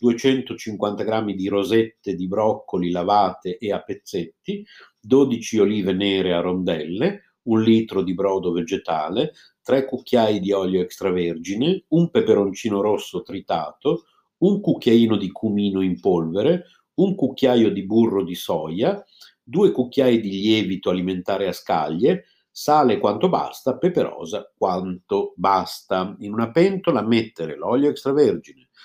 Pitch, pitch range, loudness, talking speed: 105 Hz, 95-125 Hz, -21 LUFS, 125 wpm